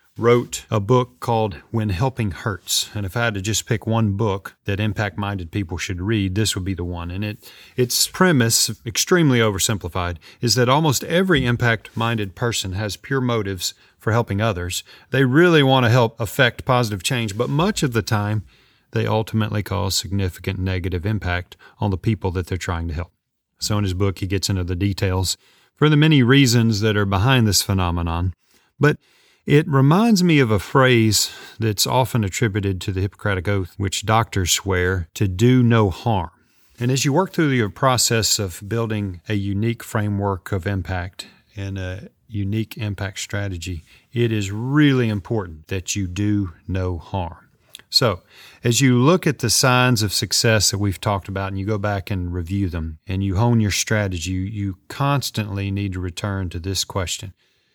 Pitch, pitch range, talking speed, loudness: 105 Hz, 95-120 Hz, 180 wpm, -20 LUFS